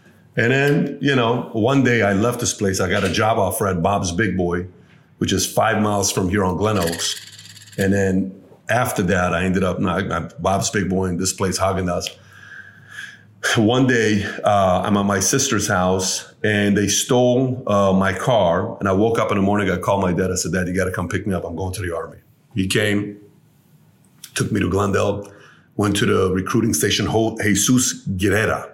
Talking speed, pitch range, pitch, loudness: 200 wpm, 95-110 Hz, 100 Hz, -19 LUFS